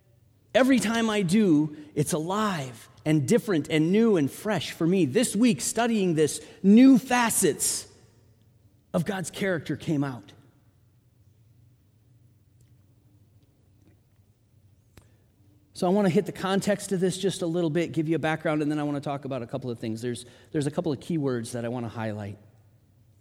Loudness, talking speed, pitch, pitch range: -25 LUFS, 170 wpm, 140 Hz, 115-180 Hz